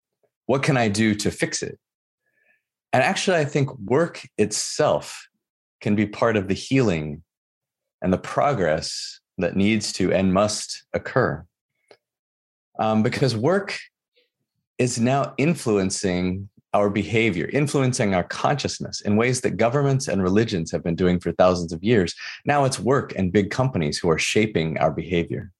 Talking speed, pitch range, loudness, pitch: 150 wpm, 90-130 Hz, -22 LUFS, 105 Hz